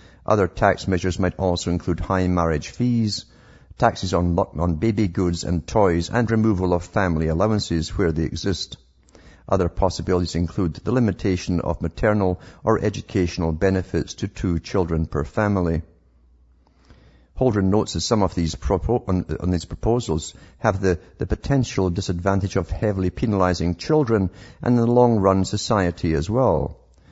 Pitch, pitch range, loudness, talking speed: 90 Hz, 85-105 Hz, -22 LUFS, 145 wpm